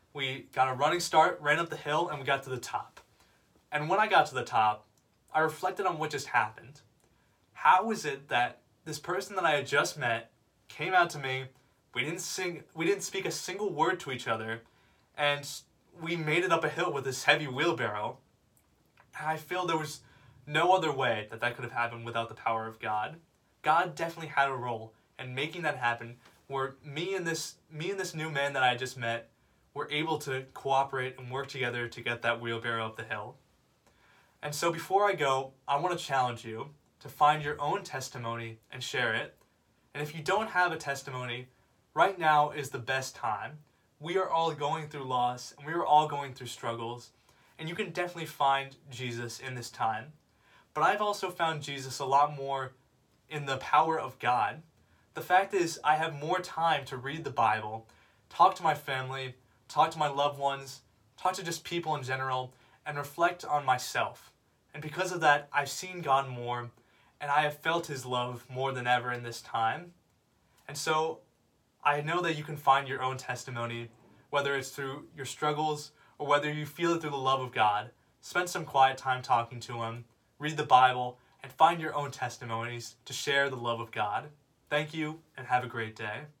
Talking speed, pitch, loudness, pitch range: 200 wpm, 140 Hz, -31 LUFS, 125-155 Hz